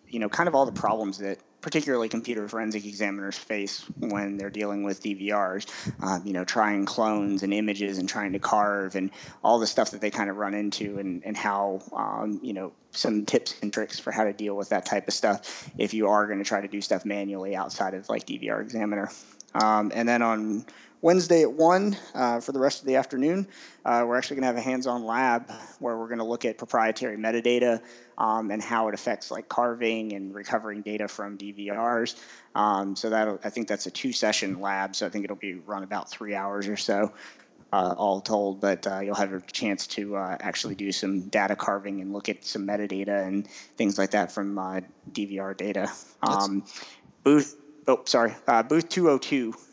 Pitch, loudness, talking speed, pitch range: 105 Hz, -27 LUFS, 210 wpm, 100-115 Hz